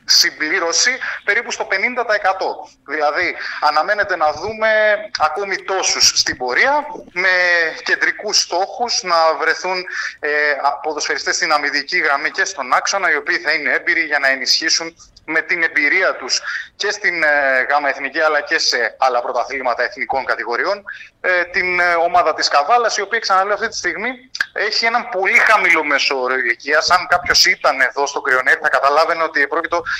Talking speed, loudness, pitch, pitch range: 150 wpm, -16 LUFS, 175 Hz, 150-210 Hz